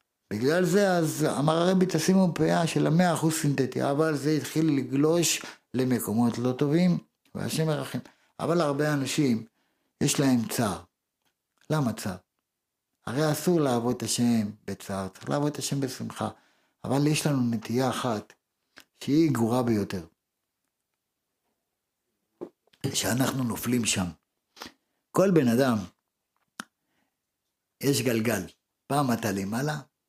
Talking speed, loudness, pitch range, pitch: 115 wpm, -26 LUFS, 115-155 Hz, 135 Hz